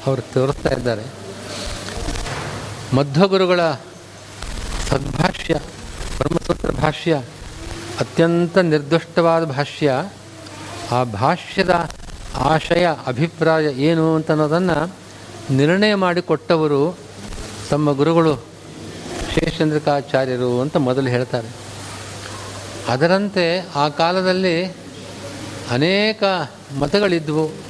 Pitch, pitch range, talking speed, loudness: 145 Hz, 115-165 Hz, 65 wpm, -19 LUFS